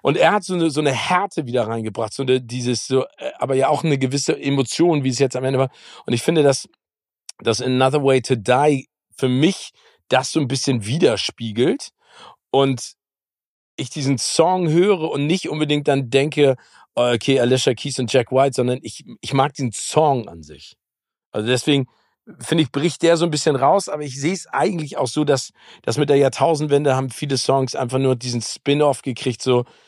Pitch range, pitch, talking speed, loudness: 125-150 Hz, 135 Hz, 195 wpm, -19 LUFS